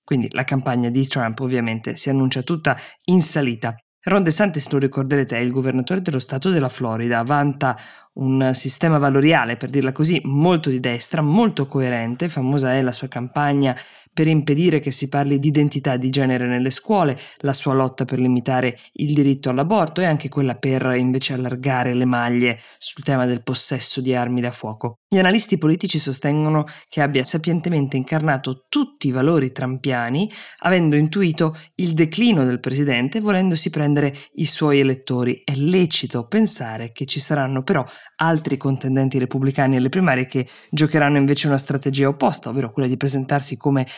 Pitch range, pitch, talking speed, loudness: 130-155 Hz, 135 Hz, 165 wpm, -20 LUFS